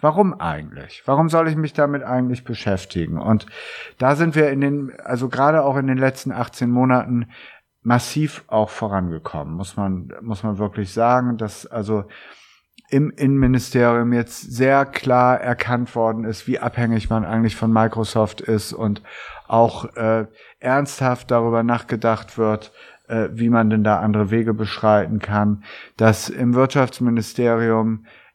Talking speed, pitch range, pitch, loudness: 145 wpm, 110-125 Hz, 115 Hz, -20 LUFS